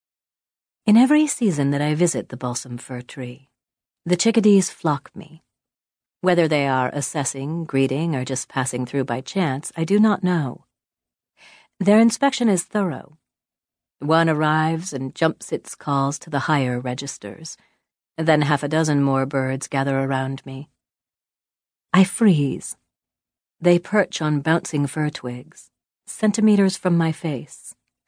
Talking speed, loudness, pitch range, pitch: 135 wpm, -21 LUFS, 135-180 Hz, 150 Hz